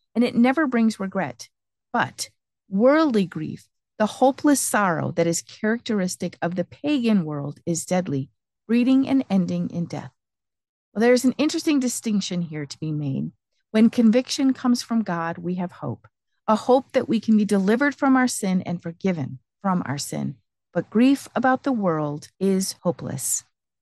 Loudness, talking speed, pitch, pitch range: -23 LUFS, 160 wpm, 195 Hz, 165-250 Hz